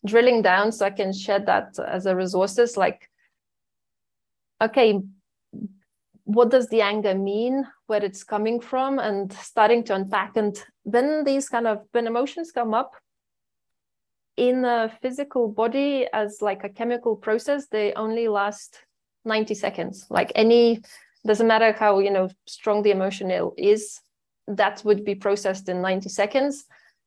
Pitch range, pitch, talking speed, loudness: 200-235 Hz, 215 Hz, 145 wpm, -23 LUFS